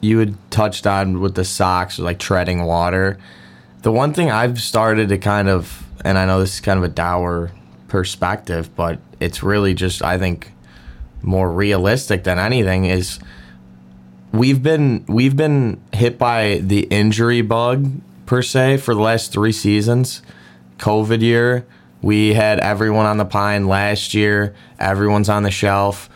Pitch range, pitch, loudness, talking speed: 90-110 Hz, 100 Hz, -17 LUFS, 160 wpm